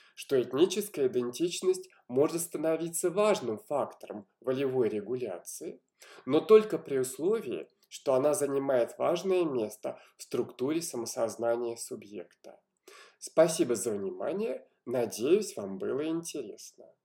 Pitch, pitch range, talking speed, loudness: 170 Hz, 130-215 Hz, 100 wpm, -30 LUFS